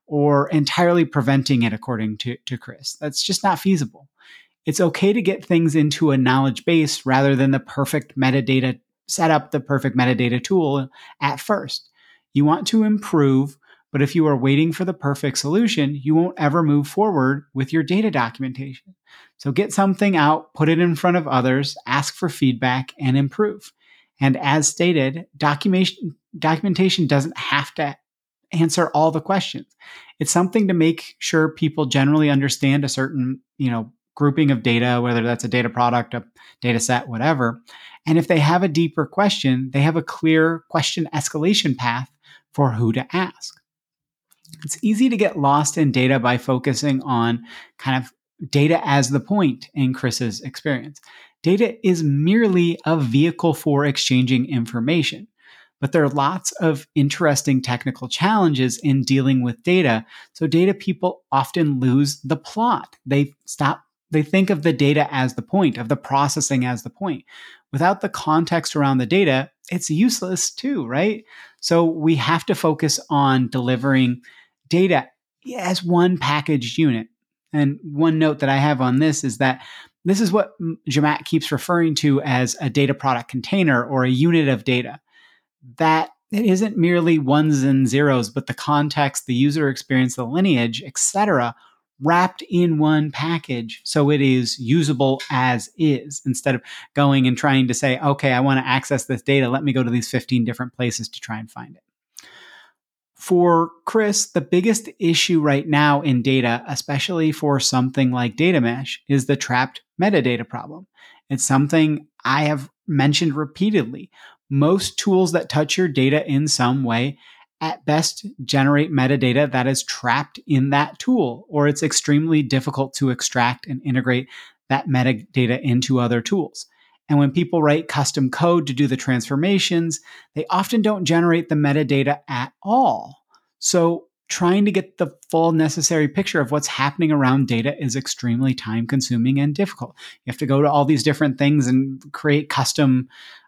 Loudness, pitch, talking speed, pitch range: -19 LUFS, 145 Hz, 165 wpm, 130-165 Hz